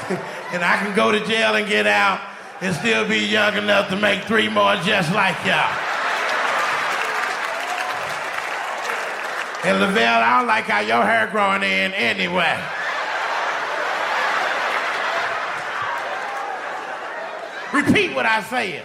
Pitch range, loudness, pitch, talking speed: 195-220 Hz, -19 LUFS, 210 Hz, 115 wpm